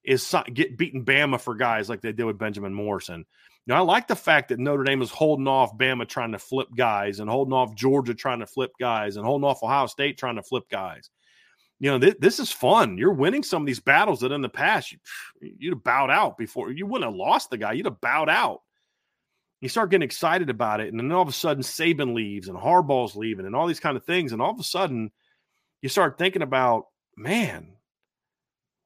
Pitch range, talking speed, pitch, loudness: 115-145 Hz, 230 wpm, 130 Hz, -24 LUFS